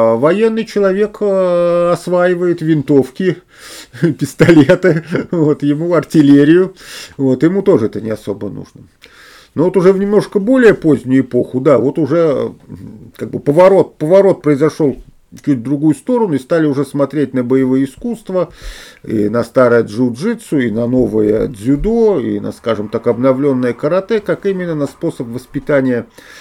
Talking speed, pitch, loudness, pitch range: 135 wpm, 150 Hz, -13 LUFS, 130-180 Hz